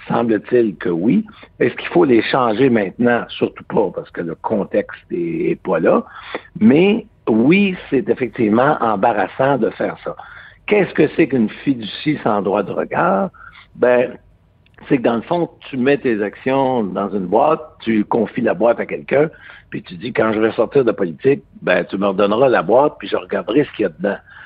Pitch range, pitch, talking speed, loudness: 115-175 Hz, 135 Hz, 190 wpm, -17 LUFS